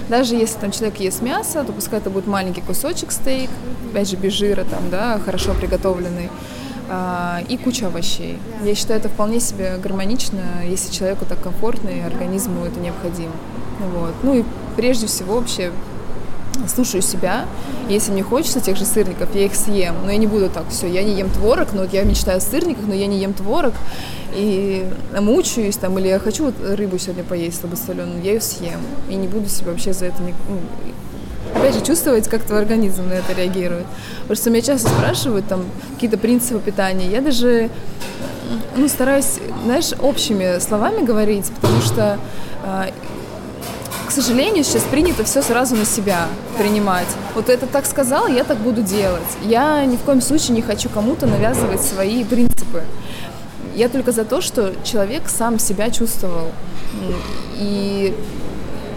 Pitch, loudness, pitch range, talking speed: 205 Hz, -19 LUFS, 185-235 Hz, 165 wpm